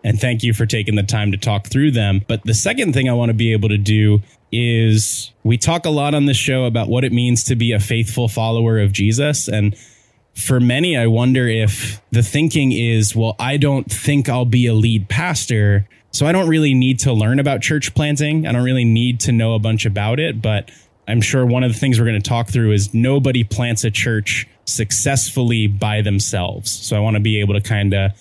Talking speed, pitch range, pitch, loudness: 230 wpm, 110-130 Hz, 115 Hz, -16 LUFS